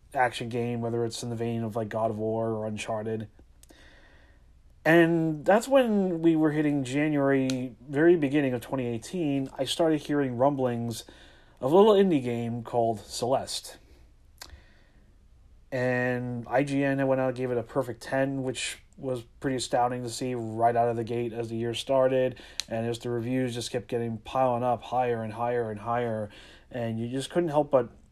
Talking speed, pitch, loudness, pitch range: 175 wpm, 125 Hz, -27 LUFS, 115-135 Hz